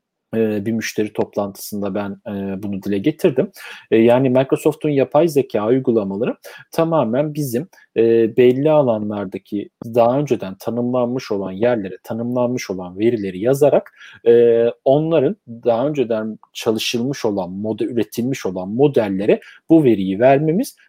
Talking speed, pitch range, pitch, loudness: 105 wpm, 105-130 Hz, 115 Hz, -18 LUFS